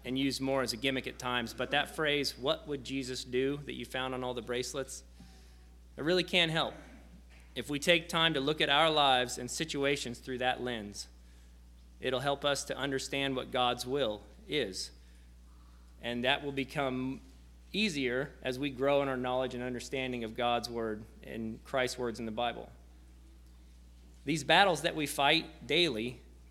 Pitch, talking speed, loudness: 125 Hz, 175 wpm, -32 LUFS